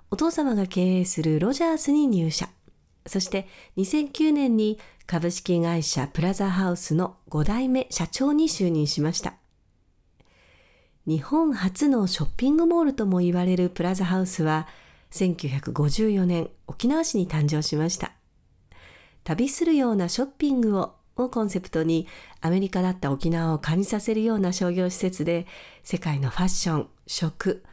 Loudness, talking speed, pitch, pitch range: -24 LUFS, 290 characters per minute, 185 Hz, 165-225 Hz